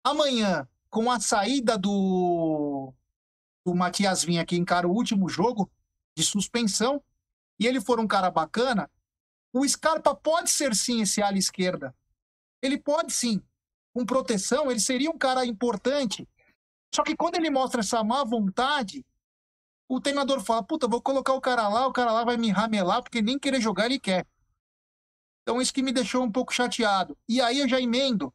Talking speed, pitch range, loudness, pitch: 170 wpm, 185-260 Hz, -25 LUFS, 235 Hz